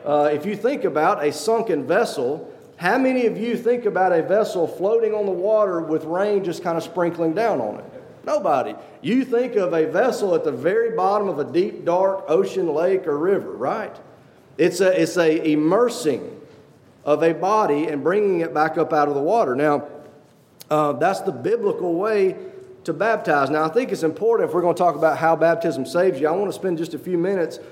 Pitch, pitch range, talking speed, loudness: 180 Hz, 160-230 Hz, 210 wpm, -21 LUFS